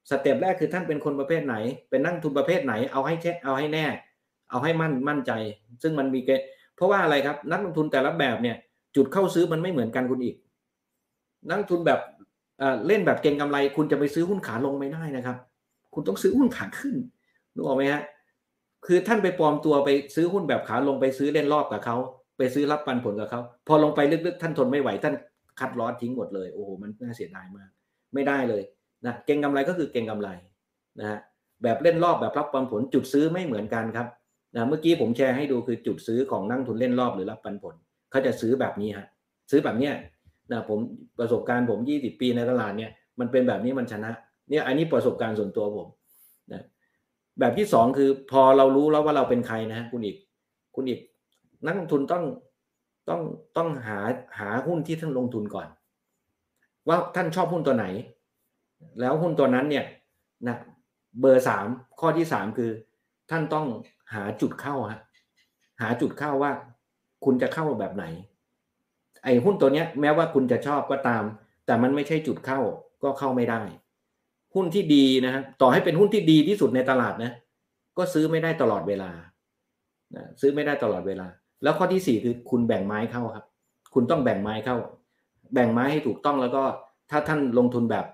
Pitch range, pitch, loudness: 120-155 Hz, 135 Hz, -25 LUFS